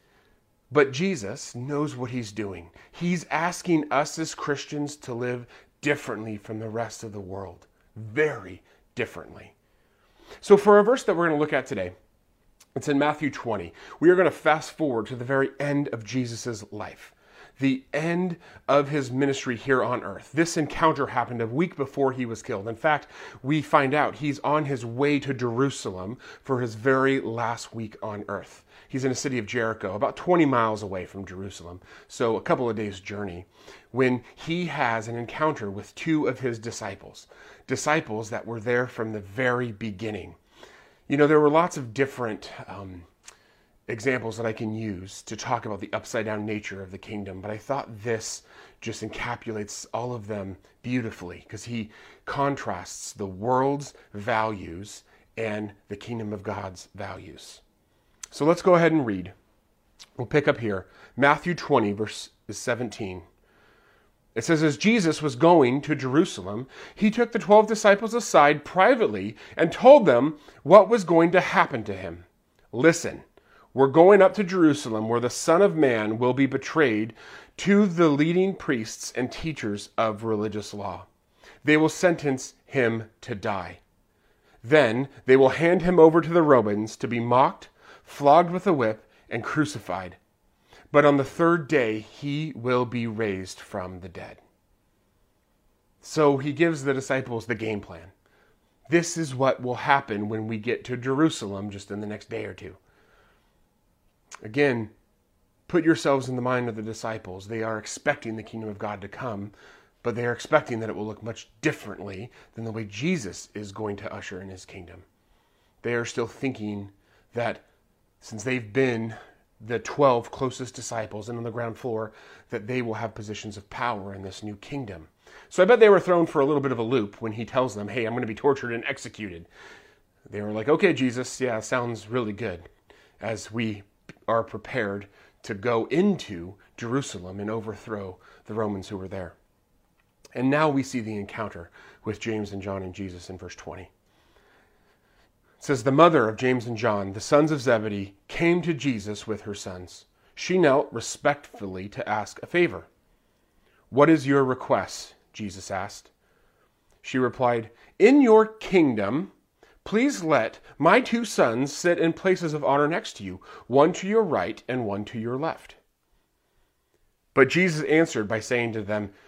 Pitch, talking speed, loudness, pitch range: 120 Hz, 170 wpm, -24 LUFS, 105-145 Hz